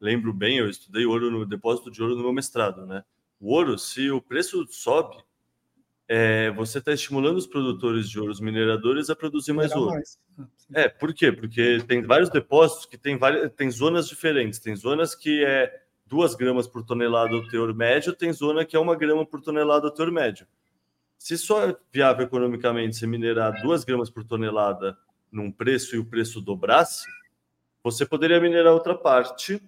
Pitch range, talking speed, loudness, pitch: 115-155 Hz, 180 wpm, -23 LUFS, 125 Hz